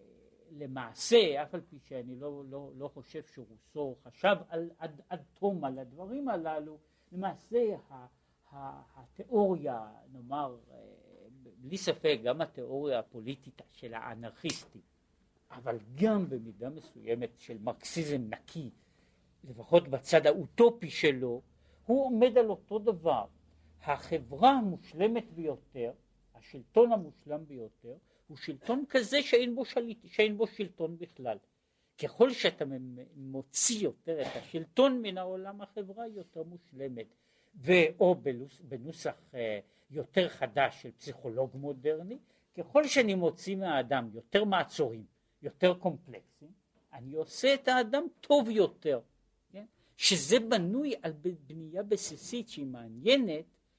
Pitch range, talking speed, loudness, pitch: 130-205 Hz, 110 wpm, -31 LUFS, 160 Hz